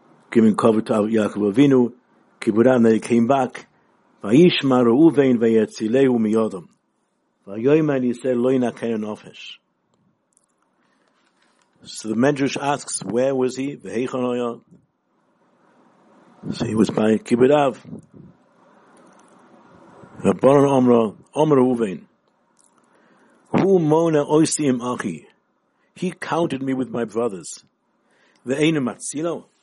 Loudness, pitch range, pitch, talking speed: -19 LUFS, 115-140 Hz, 125 Hz, 105 wpm